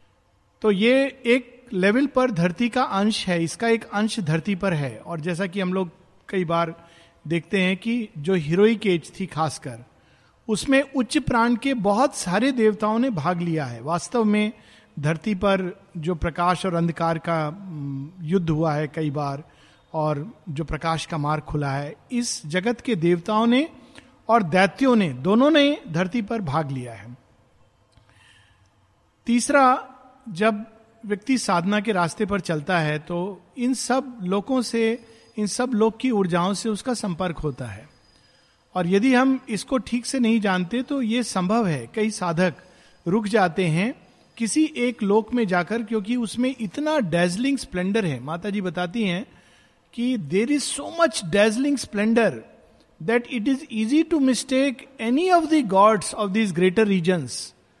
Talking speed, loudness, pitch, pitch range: 160 wpm, -23 LUFS, 205 Hz, 170-240 Hz